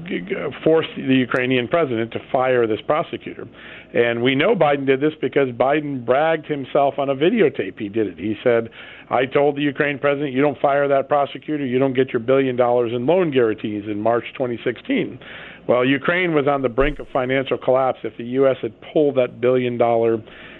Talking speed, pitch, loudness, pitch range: 190 wpm, 135 Hz, -20 LUFS, 120-145 Hz